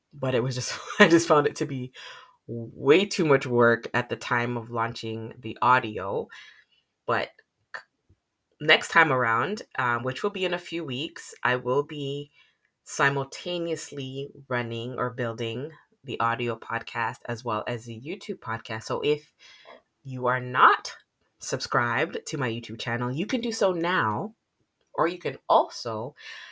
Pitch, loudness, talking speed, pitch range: 130 Hz, -26 LUFS, 155 wpm, 115-160 Hz